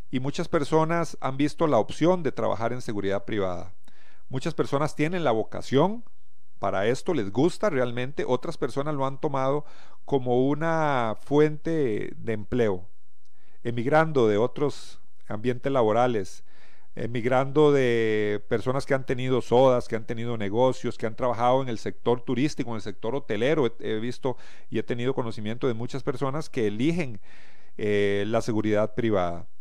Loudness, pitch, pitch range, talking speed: -26 LUFS, 125 Hz, 115-145 Hz, 150 wpm